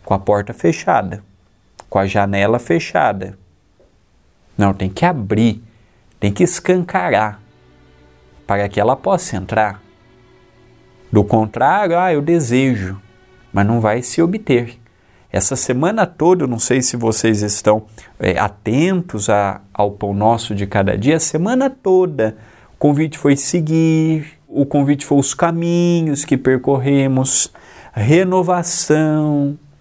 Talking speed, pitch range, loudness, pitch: 125 wpm, 100-155 Hz, -16 LUFS, 120 Hz